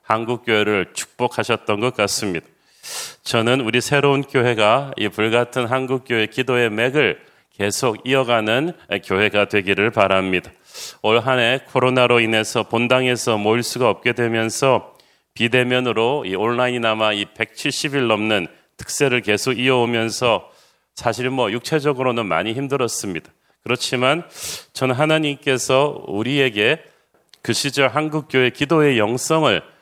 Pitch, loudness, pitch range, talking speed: 120 Hz, -19 LUFS, 110-130 Hz, 300 characters per minute